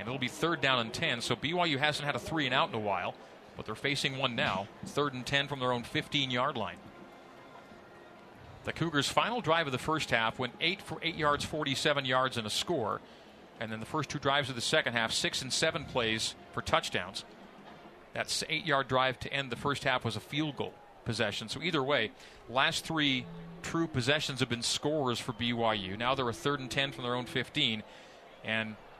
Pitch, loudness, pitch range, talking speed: 130 Hz, -31 LUFS, 120-150 Hz, 210 wpm